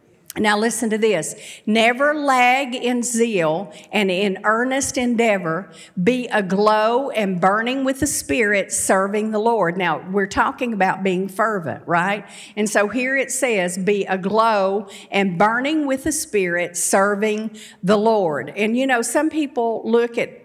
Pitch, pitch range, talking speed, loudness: 215 Hz, 195-240 Hz, 150 wpm, -19 LUFS